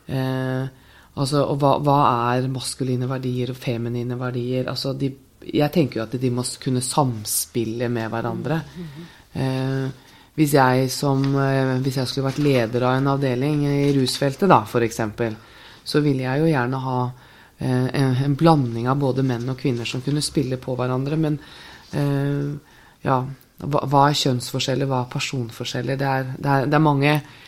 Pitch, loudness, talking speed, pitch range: 130 Hz, -22 LUFS, 160 wpm, 125-140 Hz